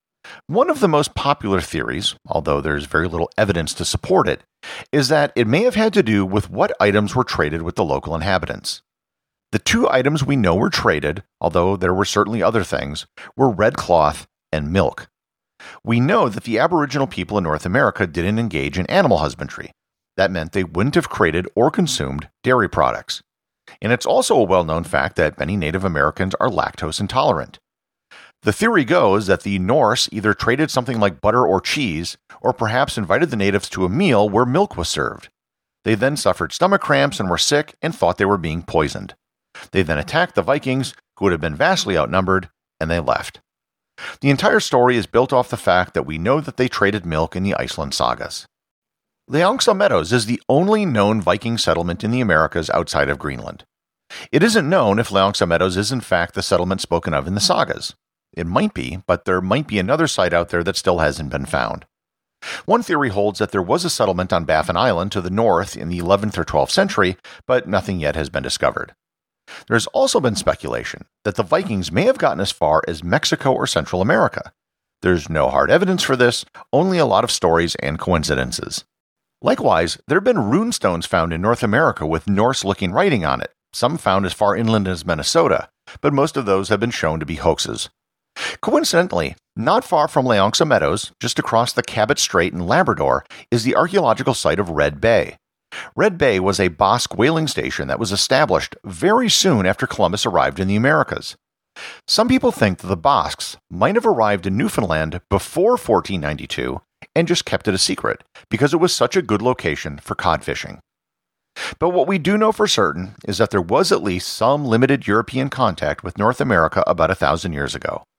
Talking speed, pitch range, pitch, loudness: 195 wpm, 85-125 Hz, 100 Hz, -18 LUFS